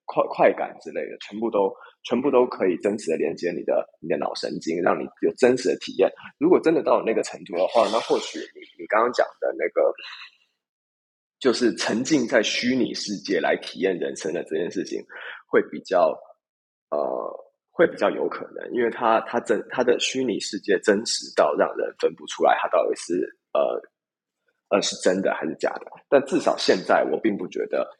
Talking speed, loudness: 275 characters per minute, -23 LUFS